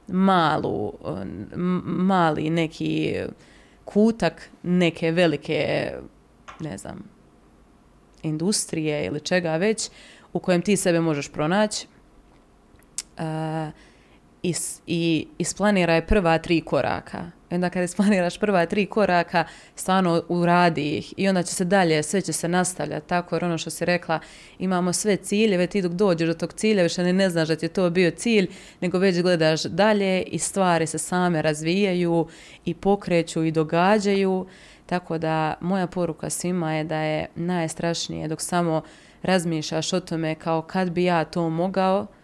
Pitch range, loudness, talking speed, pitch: 160-185 Hz, -23 LUFS, 145 wpm, 175 Hz